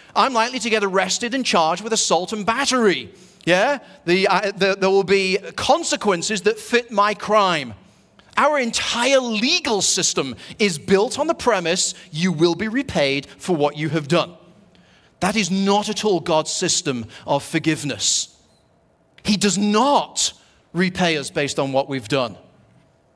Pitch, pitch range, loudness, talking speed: 190 Hz, 165-220 Hz, -19 LUFS, 155 wpm